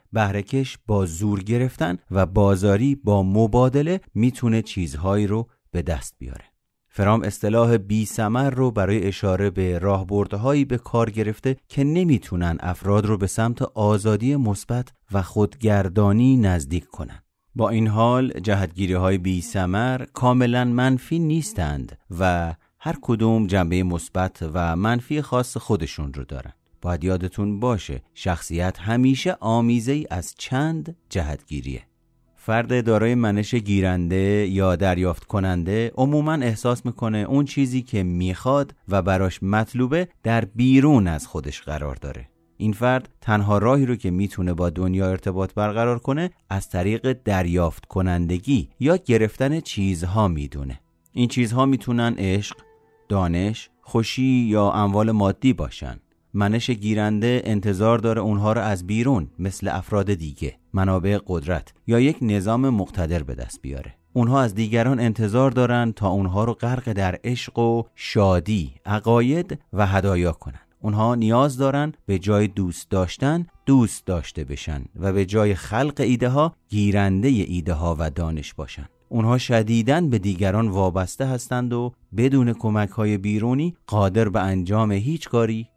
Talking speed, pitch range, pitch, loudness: 140 wpm, 95-120 Hz, 105 Hz, -22 LUFS